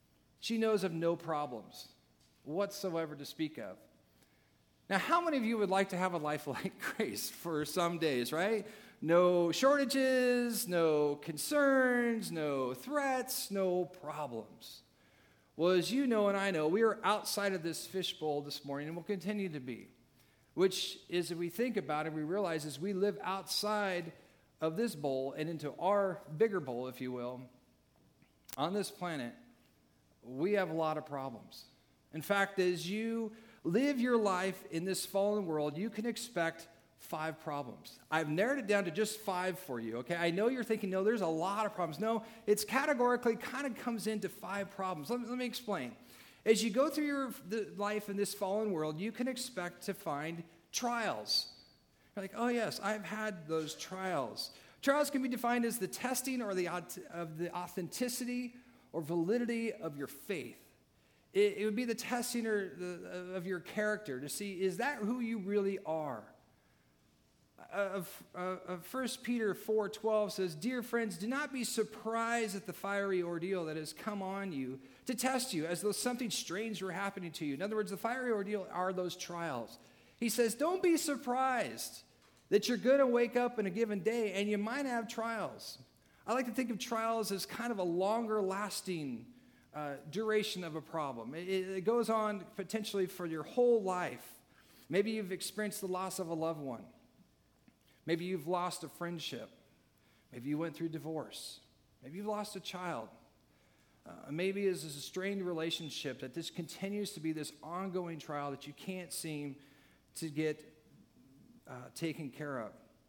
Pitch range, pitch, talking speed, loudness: 160-225 Hz, 190 Hz, 175 wpm, -36 LUFS